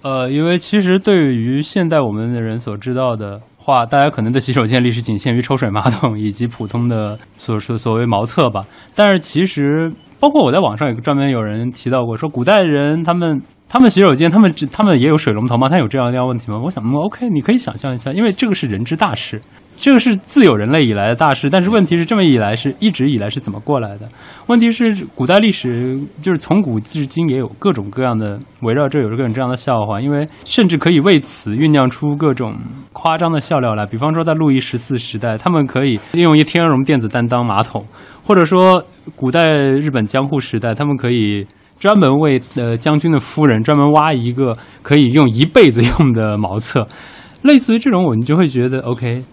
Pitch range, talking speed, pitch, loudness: 120-160 Hz, 335 characters per minute, 135 Hz, -14 LUFS